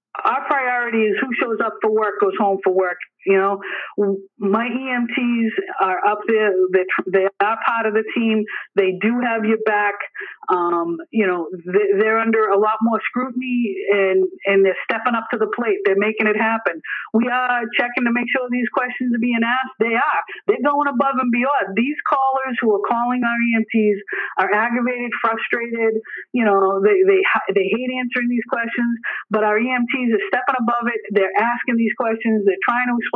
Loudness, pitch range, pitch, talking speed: -19 LUFS, 205-245 Hz, 225 Hz, 190 wpm